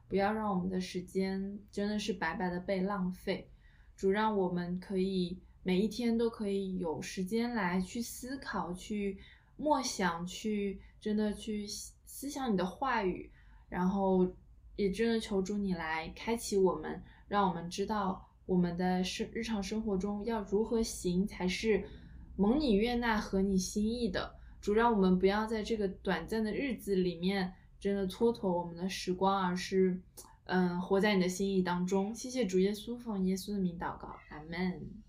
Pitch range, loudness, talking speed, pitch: 185-215 Hz, -34 LUFS, 240 characters per minute, 195 Hz